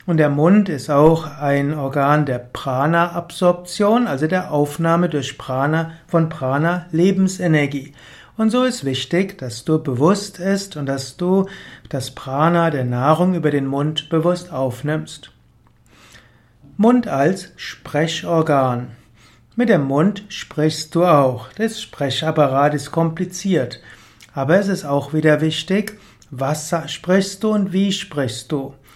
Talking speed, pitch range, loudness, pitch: 130 wpm, 135-180 Hz, -19 LUFS, 155 Hz